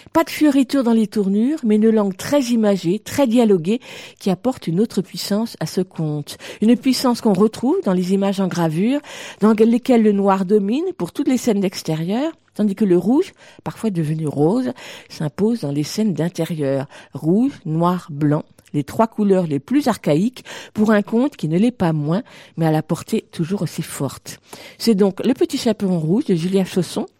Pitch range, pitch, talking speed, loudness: 170-235 Hz, 205 Hz, 190 wpm, -19 LUFS